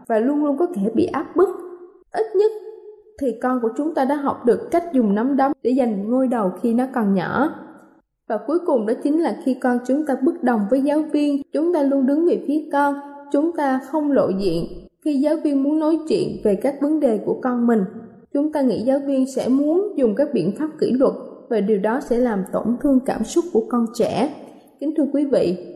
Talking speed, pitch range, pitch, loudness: 230 wpm, 240-300 Hz, 275 Hz, -20 LUFS